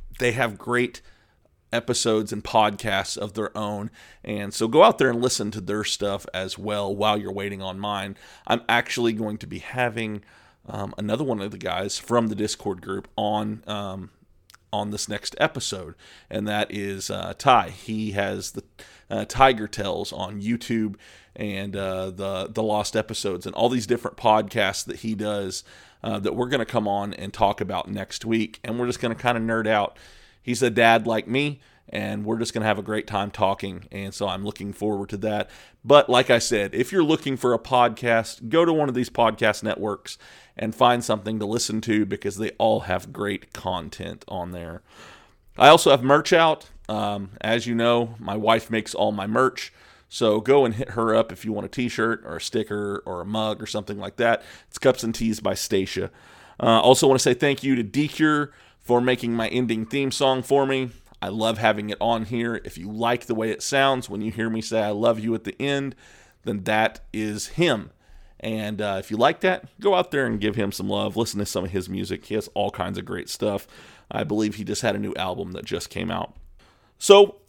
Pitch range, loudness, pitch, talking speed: 105-120 Hz, -23 LUFS, 110 Hz, 215 wpm